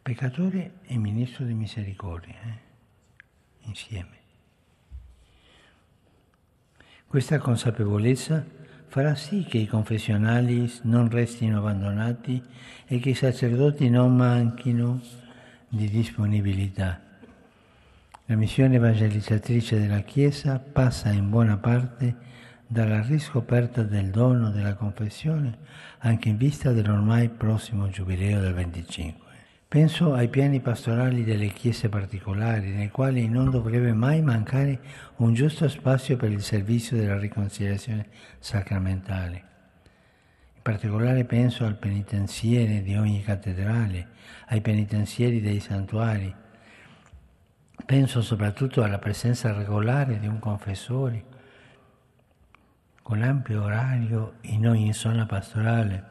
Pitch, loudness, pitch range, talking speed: 115 Hz, -25 LUFS, 105-125 Hz, 105 wpm